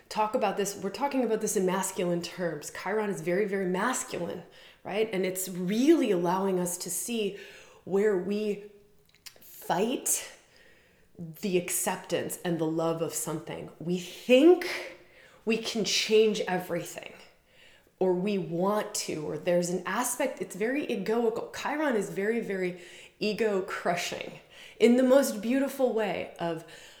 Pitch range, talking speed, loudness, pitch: 180-225 Hz, 135 wpm, -29 LUFS, 200 Hz